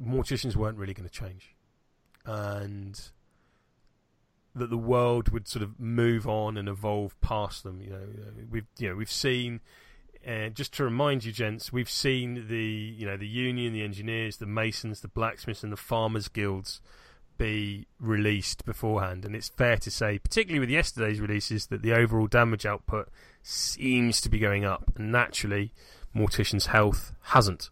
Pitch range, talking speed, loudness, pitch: 100-120 Hz, 165 wpm, -29 LUFS, 110 Hz